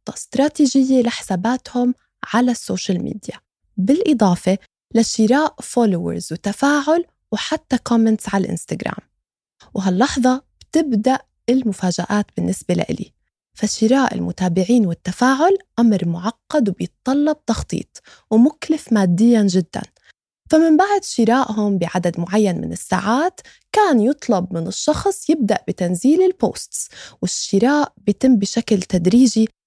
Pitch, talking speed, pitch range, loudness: 230 Hz, 95 wpm, 195-270 Hz, -18 LUFS